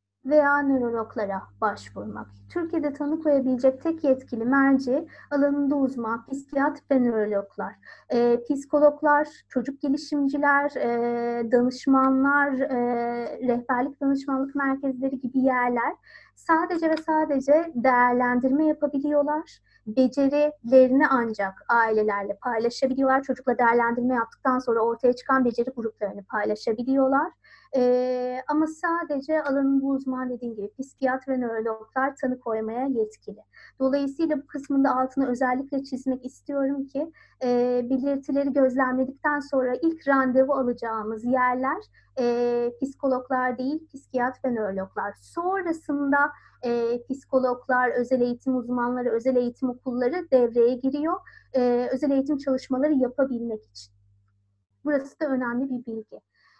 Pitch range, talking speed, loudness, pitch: 240-280 Hz, 110 wpm, -25 LUFS, 260 Hz